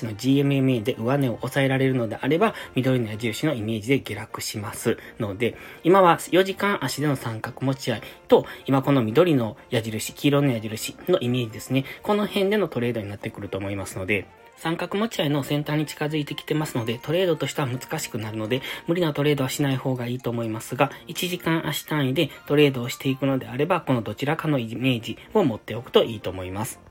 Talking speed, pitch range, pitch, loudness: 385 characters per minute, 115-150 Hz, 135 Hz, -24 LUFS